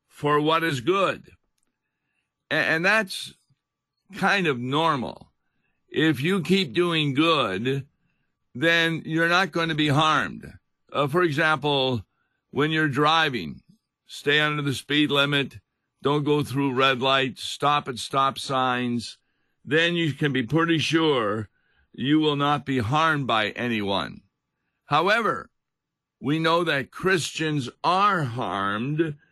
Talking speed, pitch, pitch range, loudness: 125 wpm, 150 Hz, 135-160 Hz, -23 LUFS